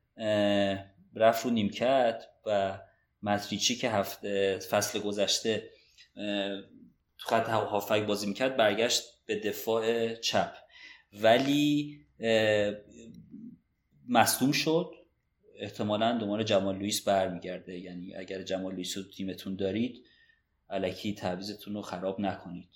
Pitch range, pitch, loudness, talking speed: 95-115 Hz, 105 Hz, -30 LUFS, 105 wpm